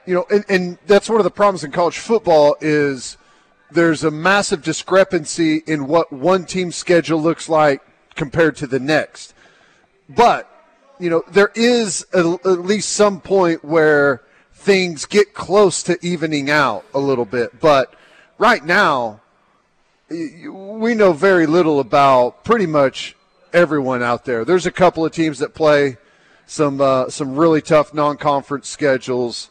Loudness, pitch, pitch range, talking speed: -16 LUFS, 165 Hz, 145-185 Hz, 155 wpm